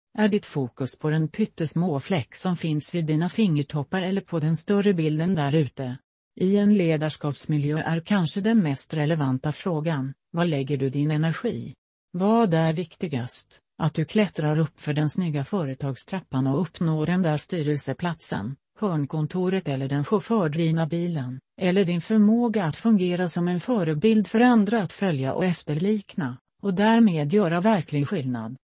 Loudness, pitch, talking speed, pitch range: -24 LUFS, 165 Hz, 150 wpm, 150-195 Hz